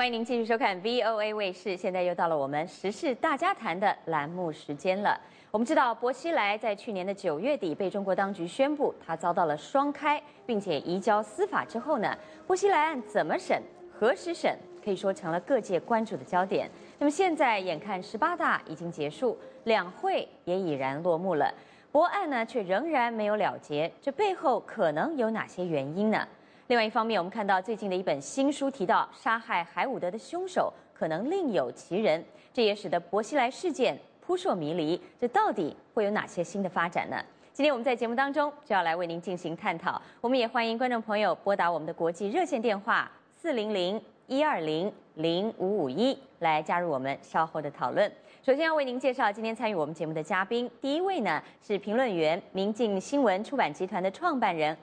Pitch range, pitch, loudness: 180-265 Hz, 210 Hz, -29 LUFS